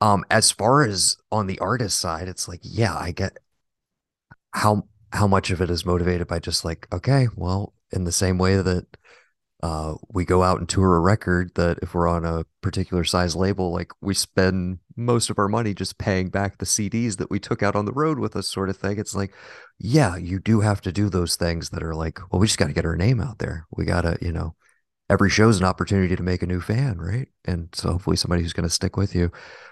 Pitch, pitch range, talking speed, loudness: 95 Hz, 85-105 Hz, 240 wpm, -23 LUFS